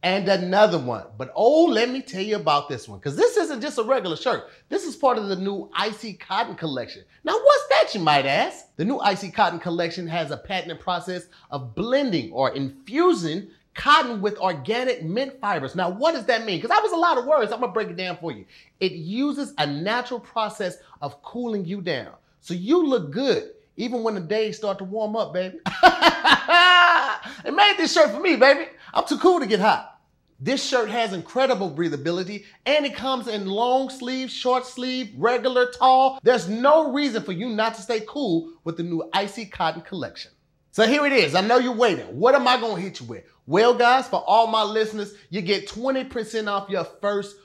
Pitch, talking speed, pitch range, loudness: 220 Hz, 205 wpm, 185-260 Hz, -22 LUFS